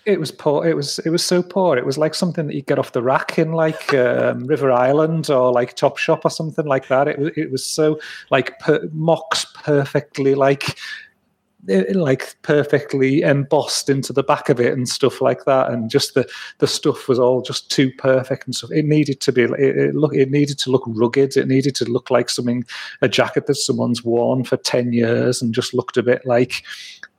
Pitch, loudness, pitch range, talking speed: 140 Hz, -18 LUFS, 125-150 Hz, 215 wpm